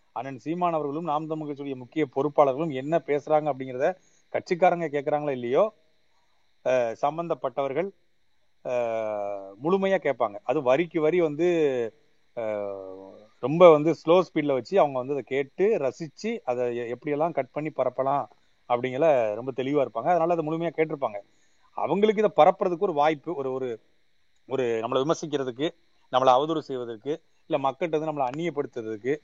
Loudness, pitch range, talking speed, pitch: -26 LUFS, 130-165 Hz, 125 wpm, 150 Hz